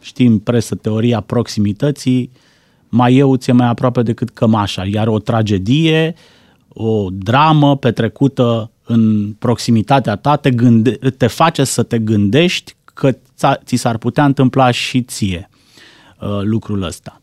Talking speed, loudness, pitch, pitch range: 130 wpm, -14 LUFS, 120 Hz, 110-130 Hz